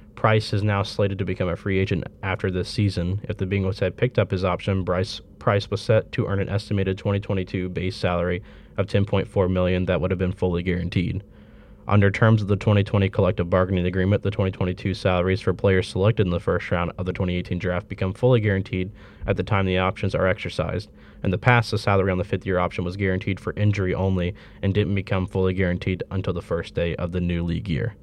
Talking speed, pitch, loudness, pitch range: 215 wpm, 95 Hz, -23 LUFS, 90-100 Hz